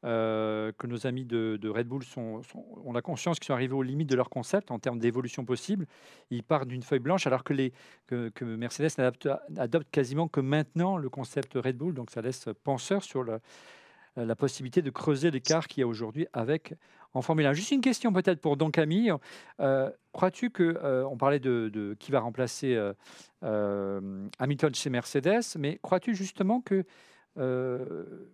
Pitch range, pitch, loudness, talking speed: 120-160 Hz, 135 Hz, -30 LUFS, 195 wpm